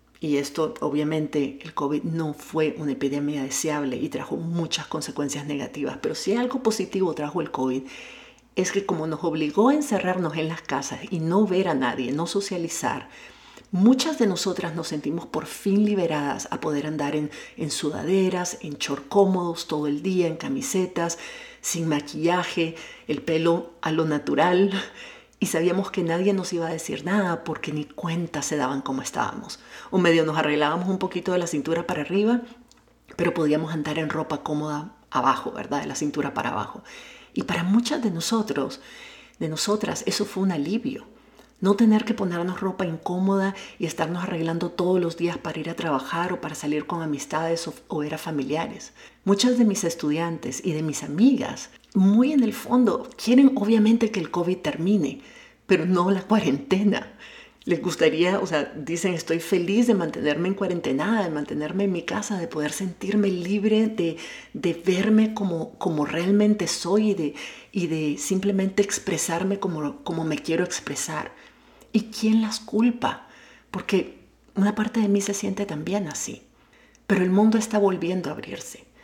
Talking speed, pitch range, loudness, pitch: 170 wpm, 155-205 Hz, -24 LUFS, 175 Hz